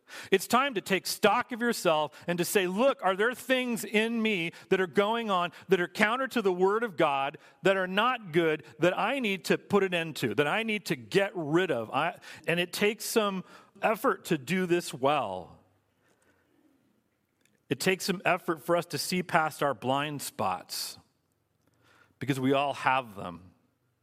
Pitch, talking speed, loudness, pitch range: 175 Hz, 185 wpm, -28 LUFS, 145-205 Hz